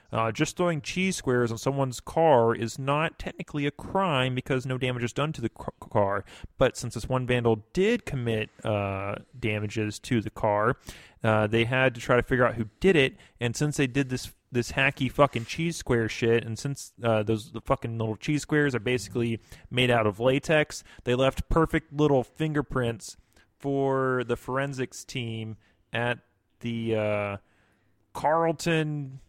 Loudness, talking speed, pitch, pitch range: -27 LUFS, 170 wpm, 125 Hz, 110-140 Hz